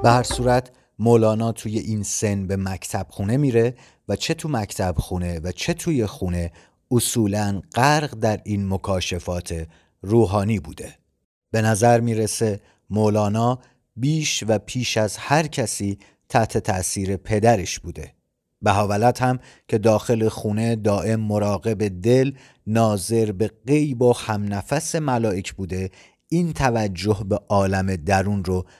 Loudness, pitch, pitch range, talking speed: -22 LUFS, 110 Hz, 100-120 Hz, 130 wpm